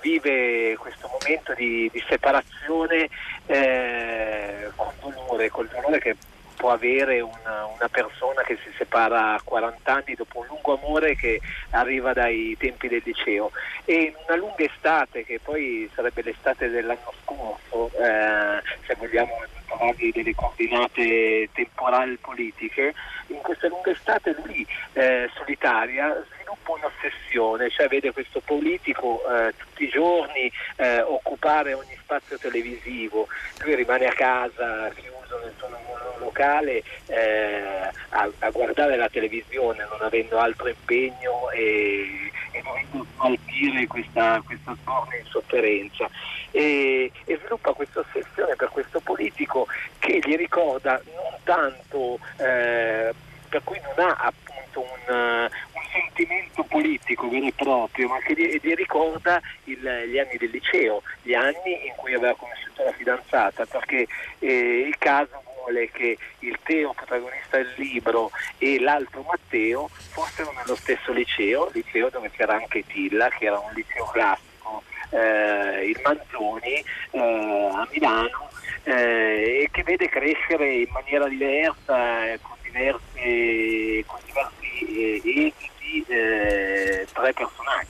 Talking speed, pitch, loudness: 130 wpm, 130 Hz, -24 LUFS